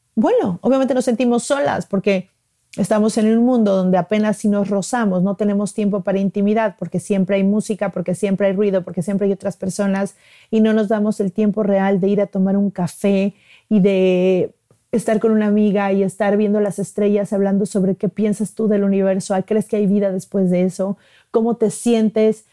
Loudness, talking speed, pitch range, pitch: -18 LUFS, 195 wpm, 195-215 Hz, 205 Hz